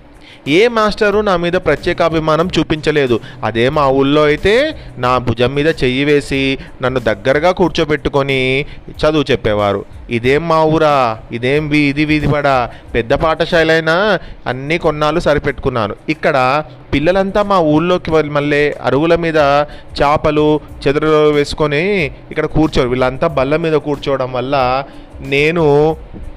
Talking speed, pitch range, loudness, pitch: 120 wpm, 135-160 Hz, -14 LUFS, 150 Hz